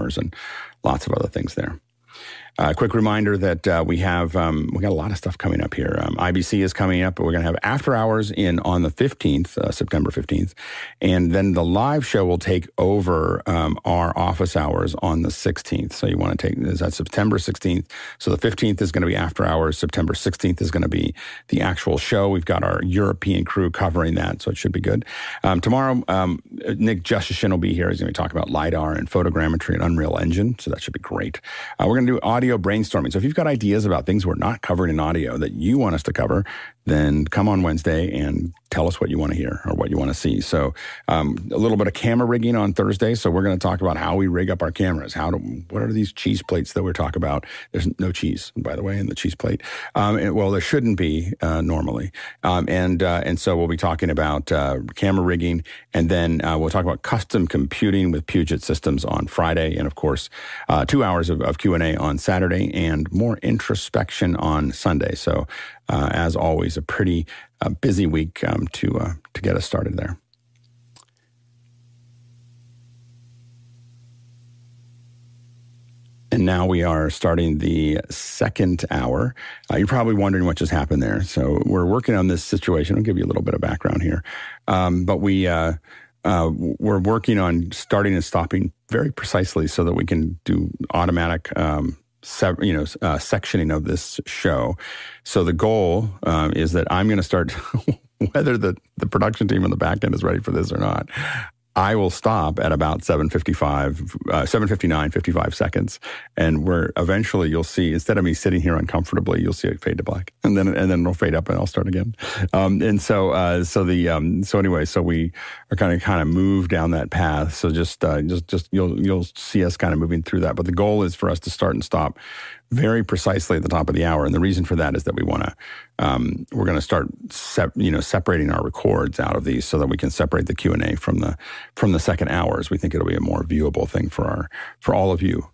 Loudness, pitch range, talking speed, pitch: -21 LUFS, 85-105 Hz, 225 wpm, 90 Hz